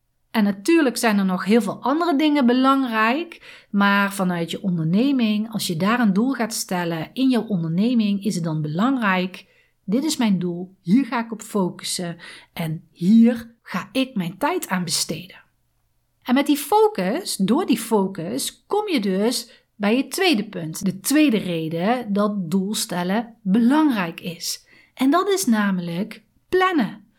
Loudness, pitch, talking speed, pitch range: -21 LUFS, 220 Hz, 155 wpm, 185-255 Hz